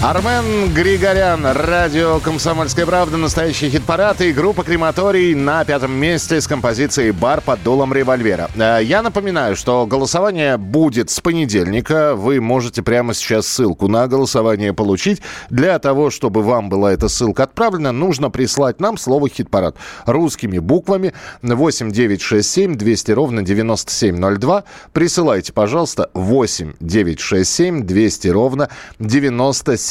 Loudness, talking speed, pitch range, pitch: -15 LUFS, 130 wpm, 110-165 Hz, 135 Hz